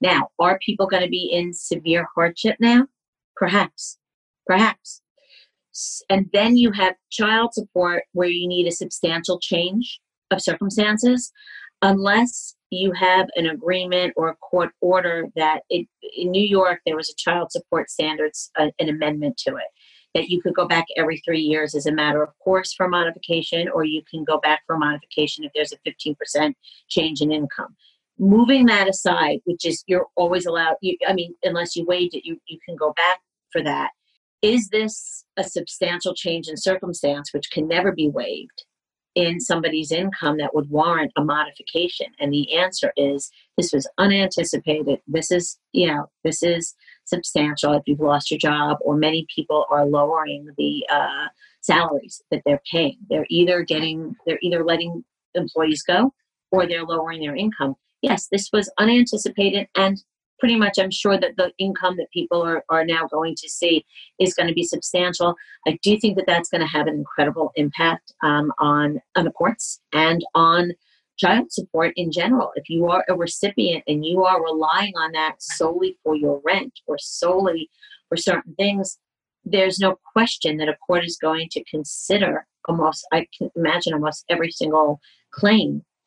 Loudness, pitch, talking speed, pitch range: -21 LUFS, 175 Hz, 175 wpm, 155-190 Hz